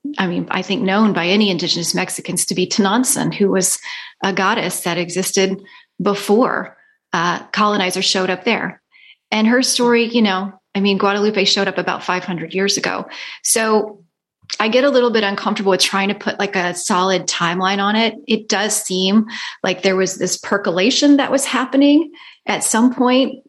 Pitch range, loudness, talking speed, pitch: 185-225 Hz, -16 LUFS, 175 wpm, 200 Hz